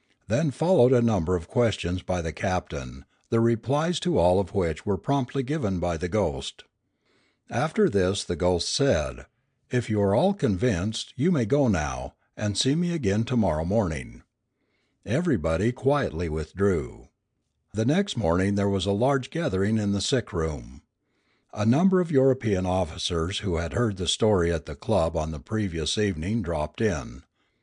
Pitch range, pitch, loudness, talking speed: 85-125 Hz, 100 Hz, -25 LUFS, 165 wpm